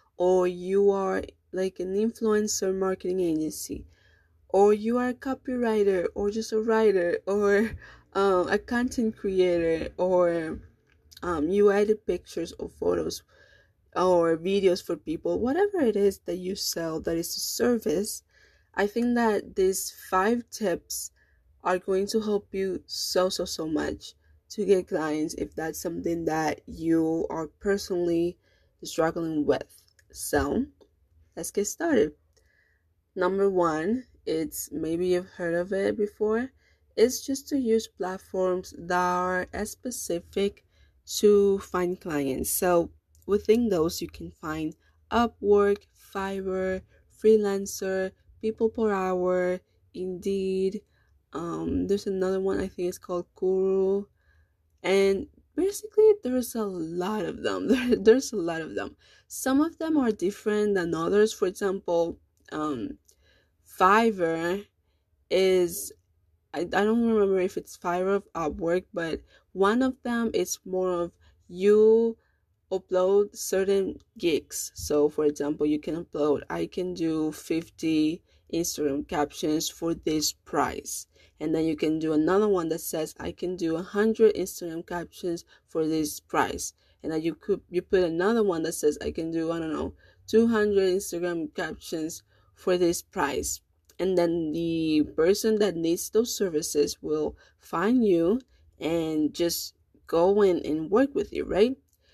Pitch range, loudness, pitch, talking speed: 160-205 Hz, -27 LUFS, 185 Hz, 140 wpm